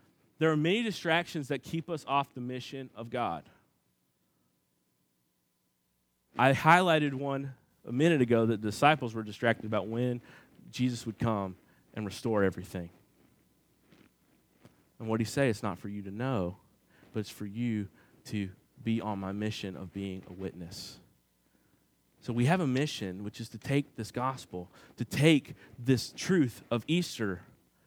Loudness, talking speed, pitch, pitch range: -31 LUFS, 155 wpm, 115 Hz, 100-135 Hz